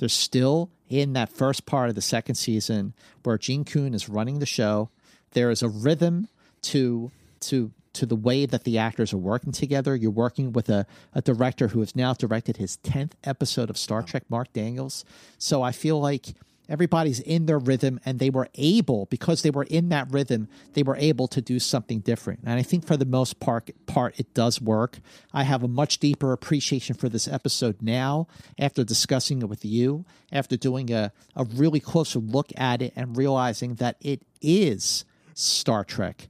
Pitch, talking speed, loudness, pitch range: 130 Hz, 195 wpm, -25 LUFS, 115-140 Hz